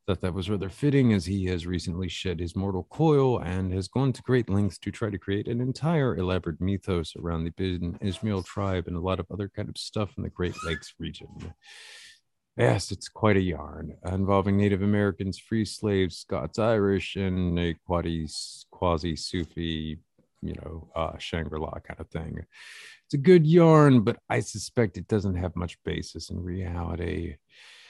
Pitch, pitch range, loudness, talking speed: 95 Hz, 85-105 Hz, -27 LUFS, 175 wpm